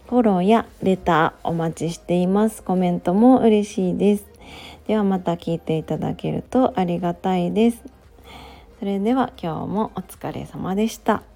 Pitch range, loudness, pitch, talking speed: 175-220 Hz, -21 LUFS, 195 Hz, 315 characters per minute